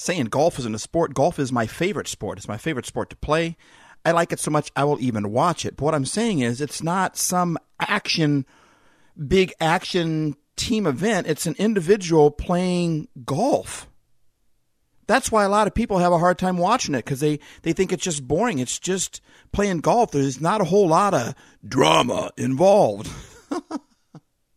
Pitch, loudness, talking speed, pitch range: 170 Hz, -22 LUFS, 185 wpm, 145-190 Hz